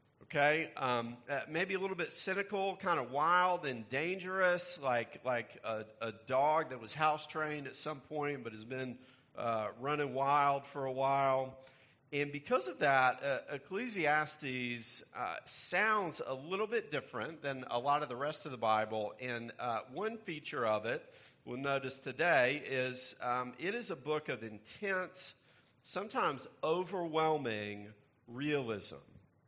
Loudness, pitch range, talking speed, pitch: -36 LUFS, 125-155 Hz, 150 wpm, 140 Hz